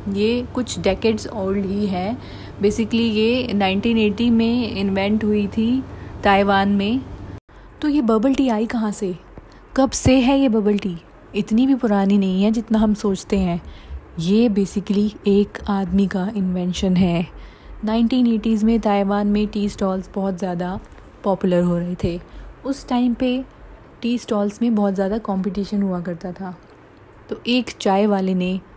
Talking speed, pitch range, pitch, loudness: 150 wpm, 195-230 Hz, 205 Hz, -20 LUFS